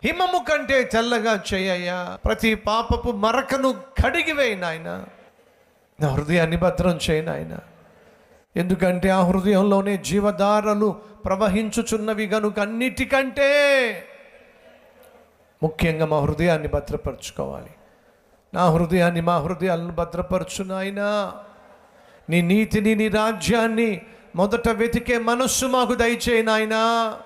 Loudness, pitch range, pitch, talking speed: -21 LUFS, 180-230 Hz, 210 Hz, 85 wpm